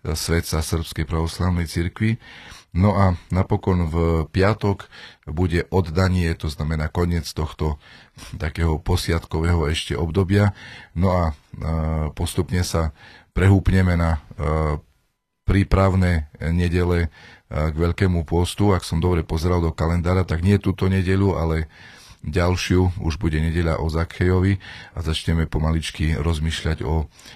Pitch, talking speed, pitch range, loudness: 85 Hz, 115 wpm, 80-95 Hz, -22 LUFS